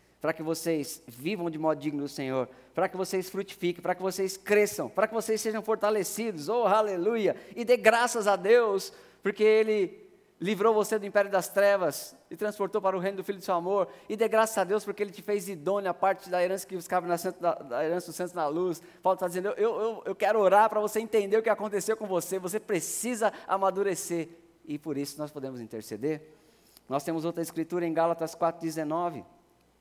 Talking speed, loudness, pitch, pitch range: 205 wpm, -29 LUFS, 190 Hz, 165-210 Hz